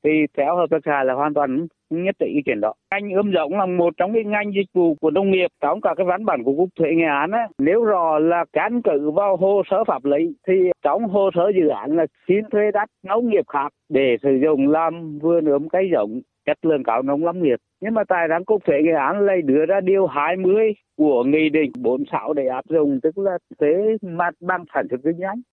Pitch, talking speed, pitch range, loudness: 170 Hz, 240 wpm, 150-195 Hz, -20 LUFS